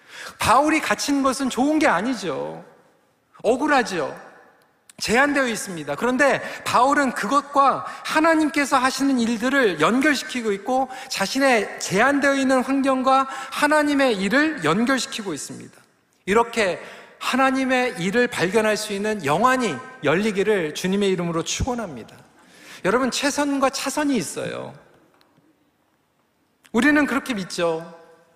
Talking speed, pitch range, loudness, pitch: 280 characters per minute, 215-275 Hz, -21 LUFS, 260 Hz